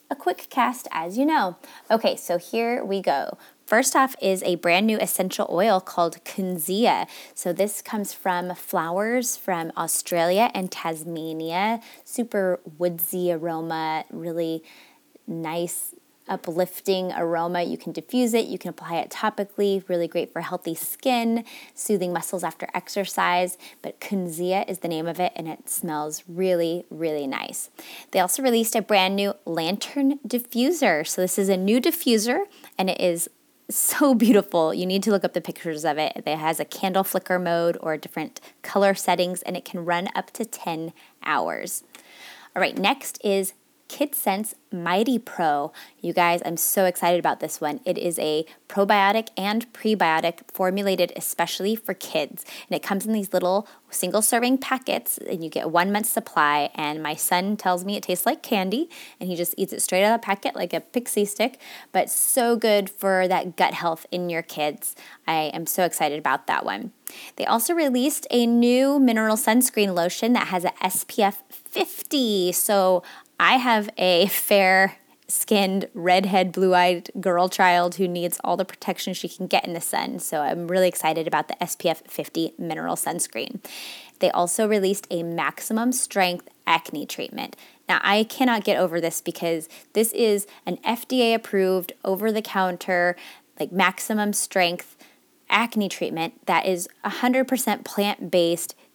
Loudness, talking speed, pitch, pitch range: -23 LUFS, 165 wpm, 190 Hz, 175-225 Hz